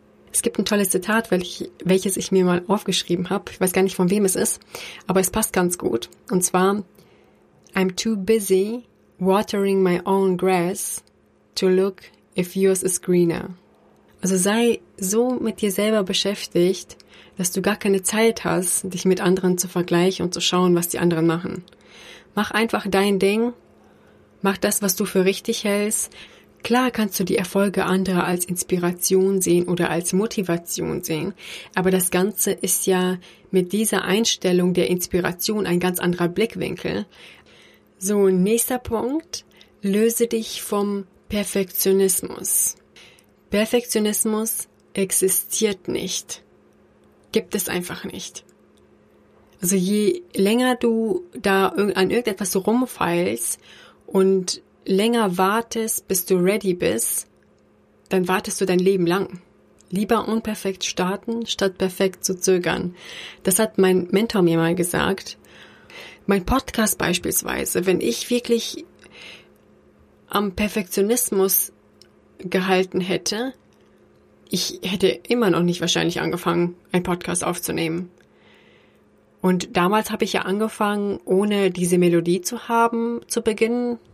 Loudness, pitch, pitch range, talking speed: -21 LUFS, 190 Hz, 180-210 Hz, 135 wpm